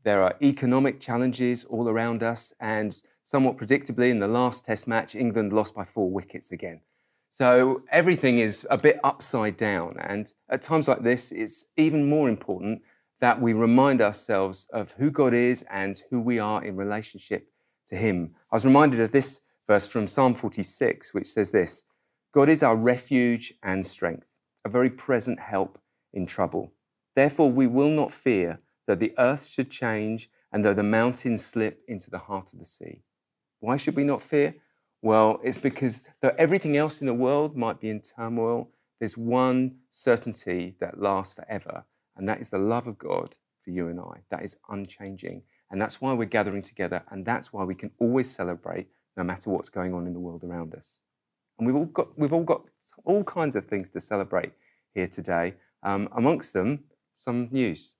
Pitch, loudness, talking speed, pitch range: 115 Hz, -25 LUFS, 185 wpm, 100-130 Hz